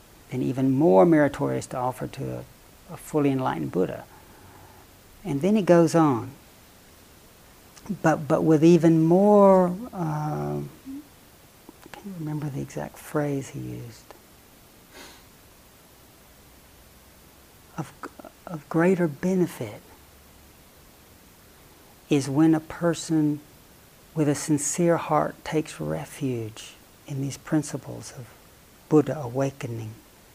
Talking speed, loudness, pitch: 100 wpm, -24 LUFS, 140 Hz